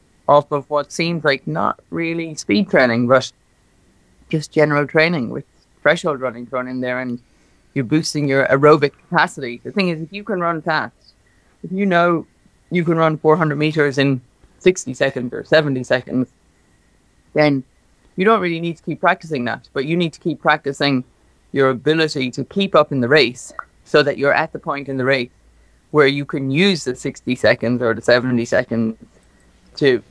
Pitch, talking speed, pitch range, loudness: 140 Hz, 180 wpm, 125-160 Hz, -18 LUFS